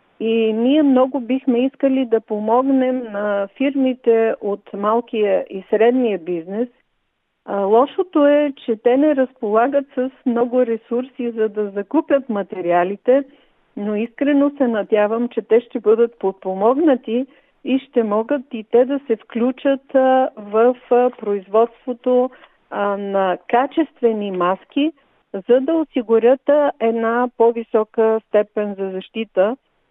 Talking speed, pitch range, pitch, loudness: 115 wpm, 215-260 Hz, 235 Hz, -18 LUFS